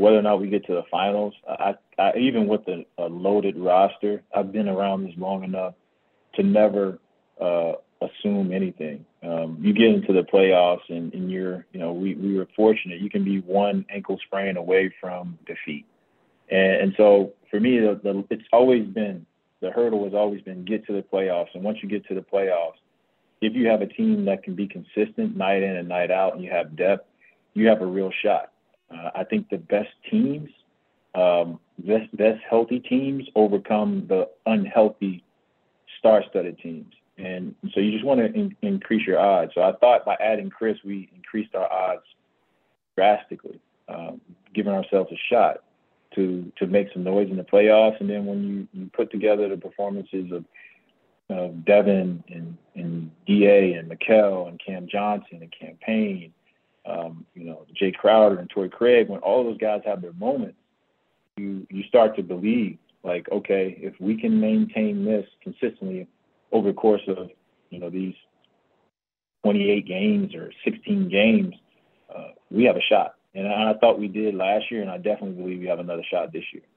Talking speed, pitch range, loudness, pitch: 185 wpm, 95-110 Hz, -23 LUFS, 100 Hz